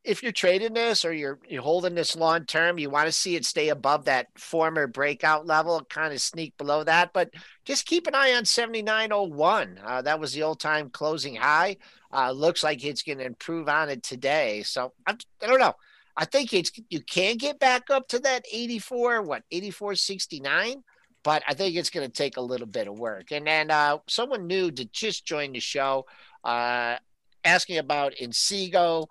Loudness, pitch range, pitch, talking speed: -25 LUFS, 150-215 Hz, 165 Hz, 195 wpm